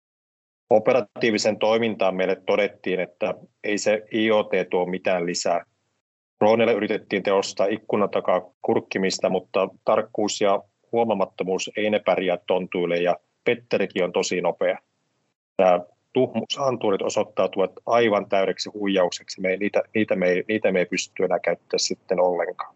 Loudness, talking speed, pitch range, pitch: -23 LUFS, 130 wpm, 95-110 Hz, 100 Hz